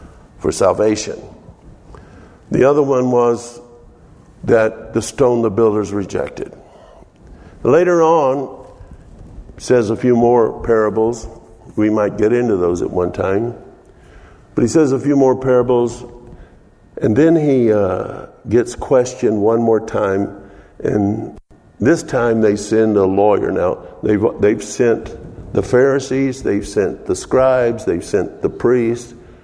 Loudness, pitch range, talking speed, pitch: -16 LUFS, 105-130 Hz, 130 wpm, 120 Hz